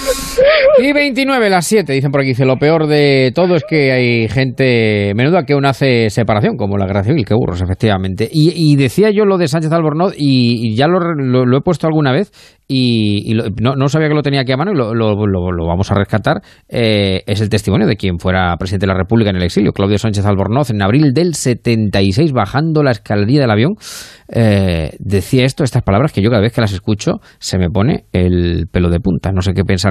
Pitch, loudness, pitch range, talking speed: 120 Hz, -13 LUFS, 100-150 Hz, 230 wpm